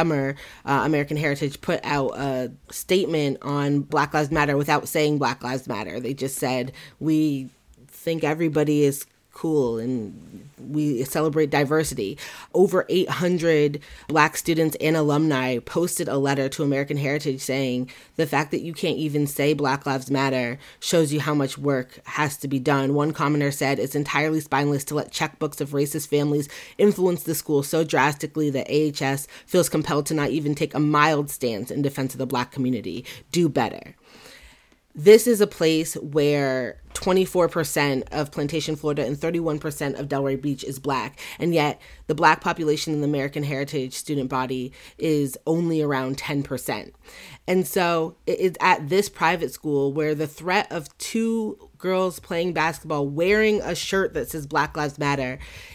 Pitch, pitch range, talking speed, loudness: 150 Hz, 140-160 Hz, 165 wpm, -23 LUFS